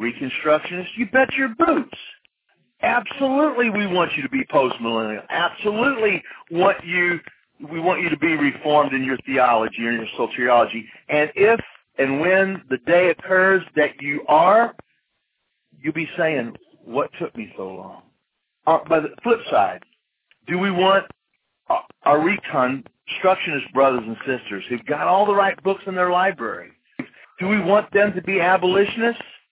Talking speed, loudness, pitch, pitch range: 150 wpm, -20 LUFS, 180 Hz, 145-205 Hz